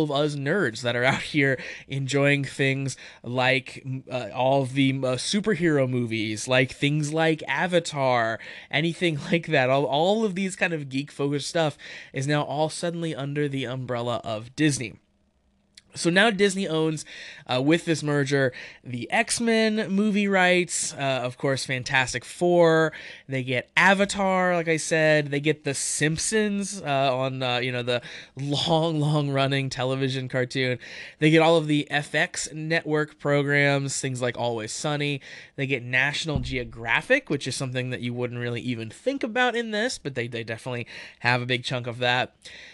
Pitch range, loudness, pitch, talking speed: 130-165 Hz, -24 LUFS, 140 Hz, 170 wpm